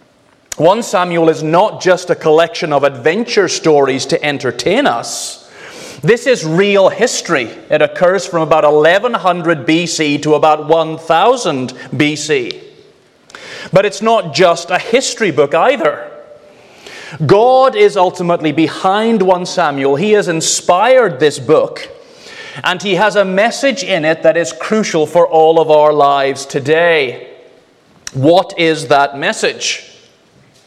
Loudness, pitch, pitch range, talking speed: -12 LUFS, 170 Hz, 155-215 Hz, 130 wpm